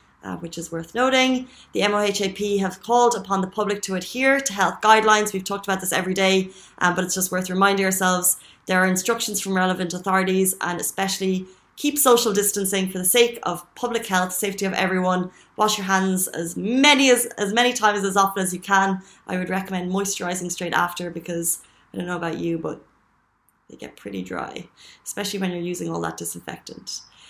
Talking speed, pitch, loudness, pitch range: 195 wpm, 190 Hz, -21 LUFS, 180-205 Hz